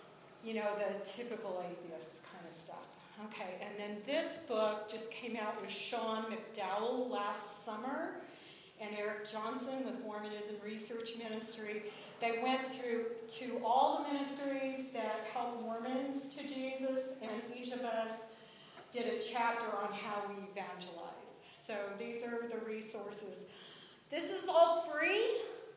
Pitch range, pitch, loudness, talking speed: 210-250 Hz, 225 Hz, -39 LUFS, 140 wpm